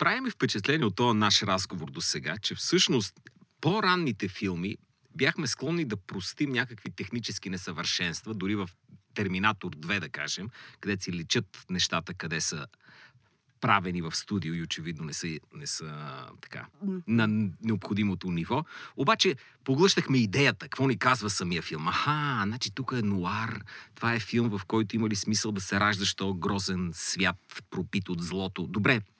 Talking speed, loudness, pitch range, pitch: 155 wpm, -29 LUFS, 95-125 Hz, 105 Hz